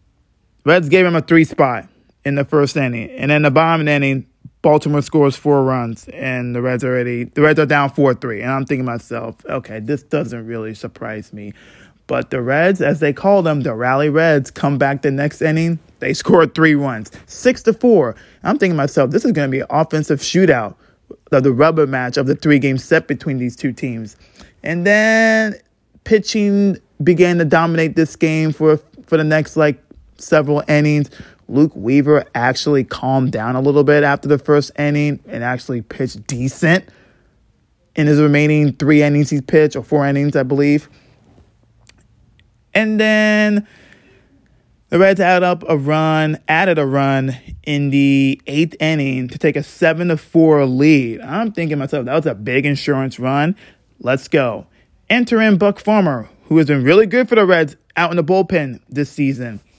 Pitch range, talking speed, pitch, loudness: 130-160 Hz, 185 wpm, 145 Hz, -15 LUFS